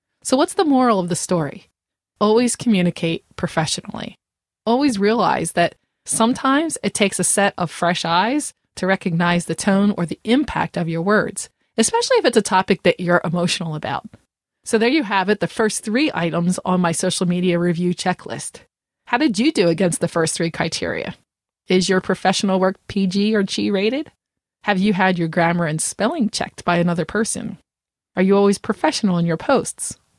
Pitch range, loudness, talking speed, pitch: 175-220 Hz, -19 LUFS, 180 wpm, 190 Hz